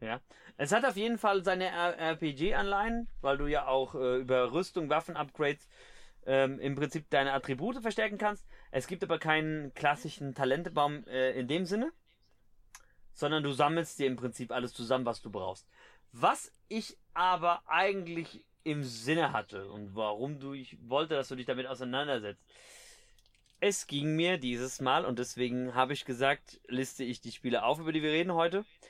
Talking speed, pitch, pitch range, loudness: 170 wpm, 145 Hz, 130-165 Hz, -33 LUFS